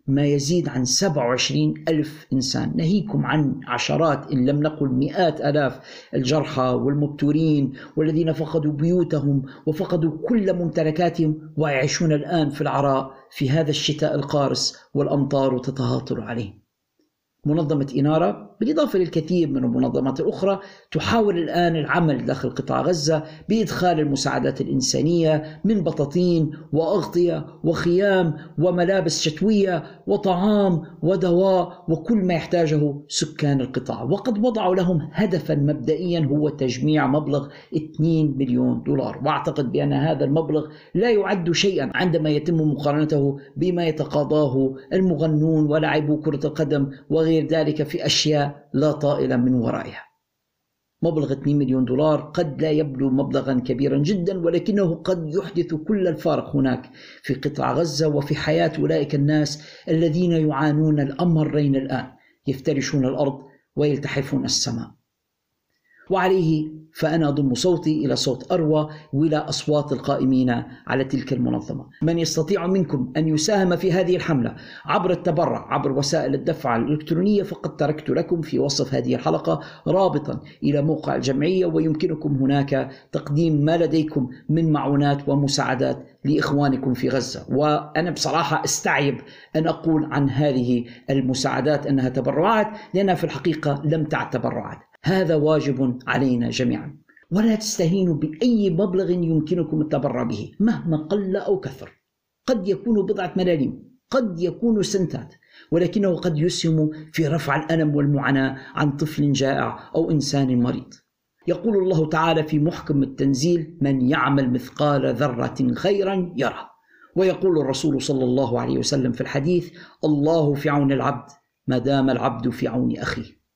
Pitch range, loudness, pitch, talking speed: 140-175 Hz, -22 LUFS, 155 Hz, 125 wpm